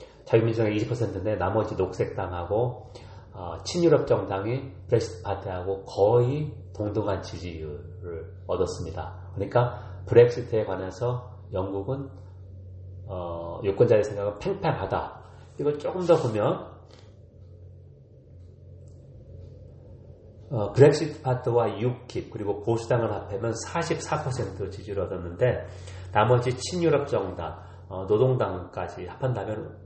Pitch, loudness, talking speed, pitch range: 105 Hz, -26 LUFS, 240 characters per minute, 95-120 Hz